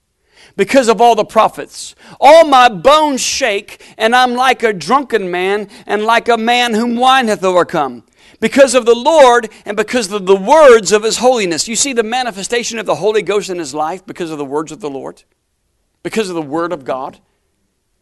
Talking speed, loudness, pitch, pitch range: 195 wpm, -12 LUFS, 220 Hz, 180-245 Hz